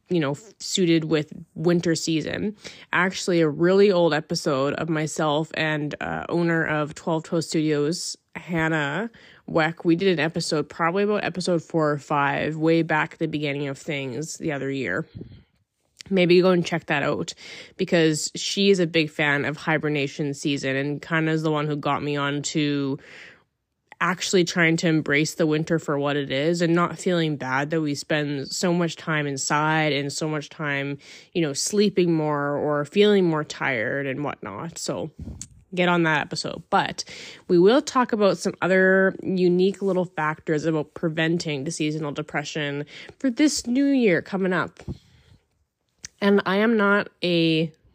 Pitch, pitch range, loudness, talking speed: 160 Hz, 145-175 Hz, -23 LUFS, 165 wpm